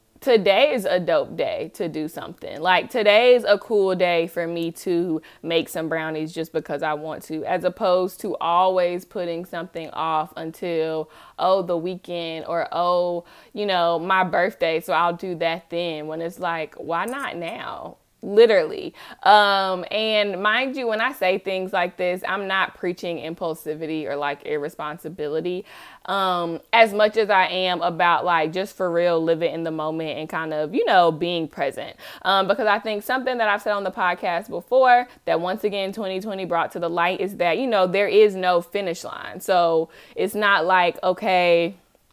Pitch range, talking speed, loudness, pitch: 165-195 Hz, 180 wpm, -22 LUFS, 175 Hz